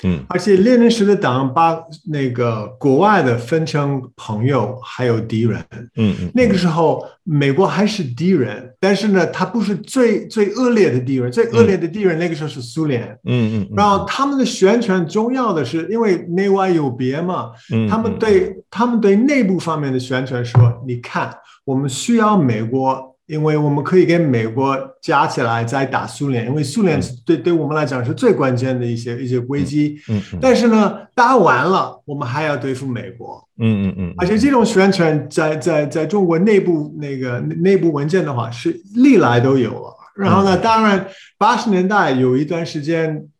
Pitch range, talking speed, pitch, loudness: 130-195 Hz, 270 characters per minute, 155 Hz, -16 LUFS